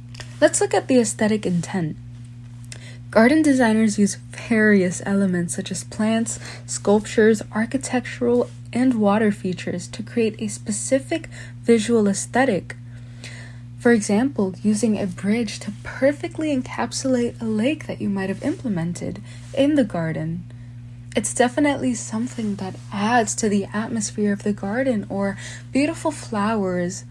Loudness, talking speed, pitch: -21 LUFS, 125 wpm, 195 Hz